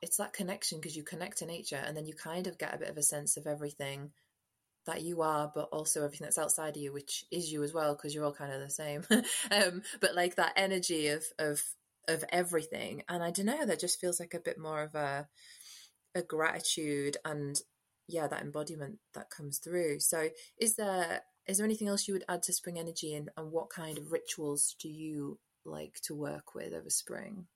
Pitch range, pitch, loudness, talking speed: 150-175 Hz, 160 Hz, -35 LUFS, 220 wpm